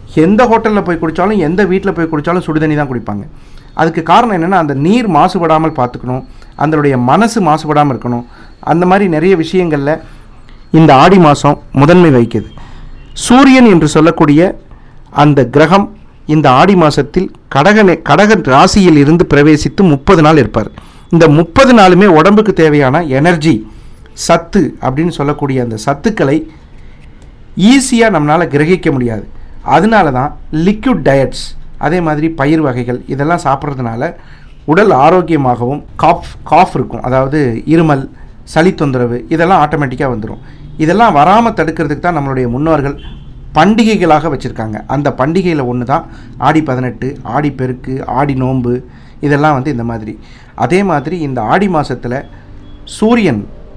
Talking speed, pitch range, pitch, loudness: 125 wpm, 130-175 Hz, 150 Hz, -10 LUFS